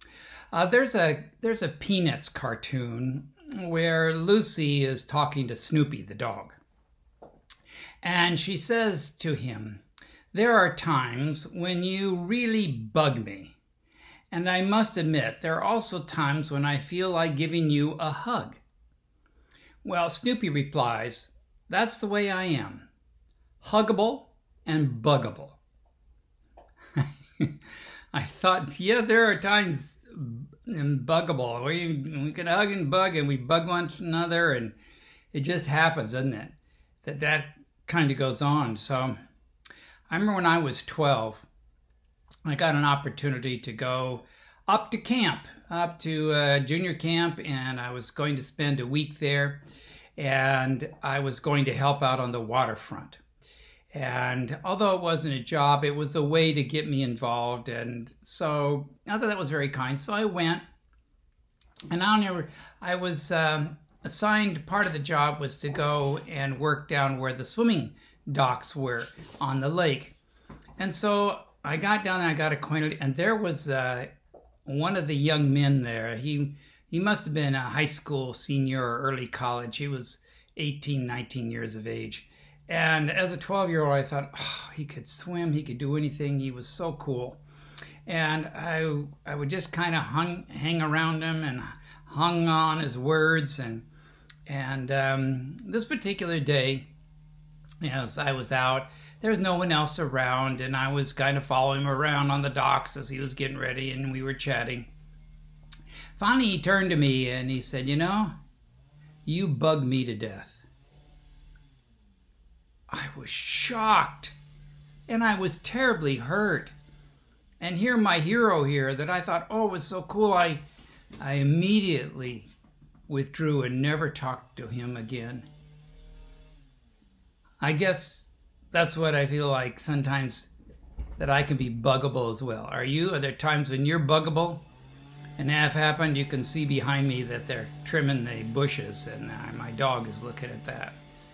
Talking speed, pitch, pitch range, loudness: 160 wpm, 145 Hz, 130-165 Hz, -27 LUFS